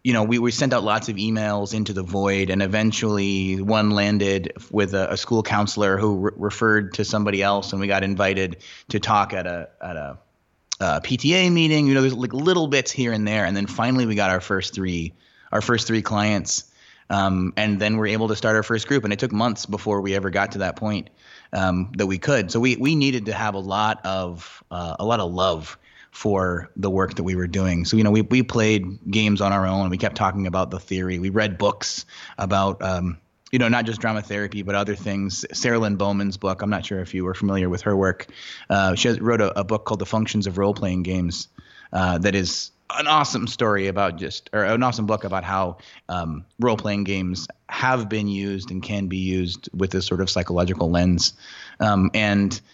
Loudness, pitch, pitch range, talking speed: -22 LUFS, 100 Hz, 95-110 Hz, 225 wpm